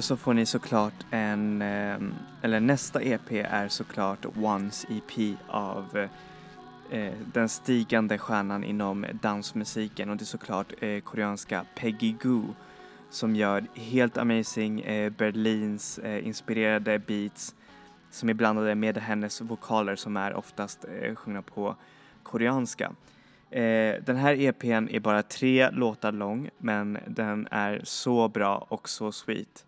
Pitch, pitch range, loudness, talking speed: 110 Hz, 105-115 Hz, -29 LUFS, 135 wpm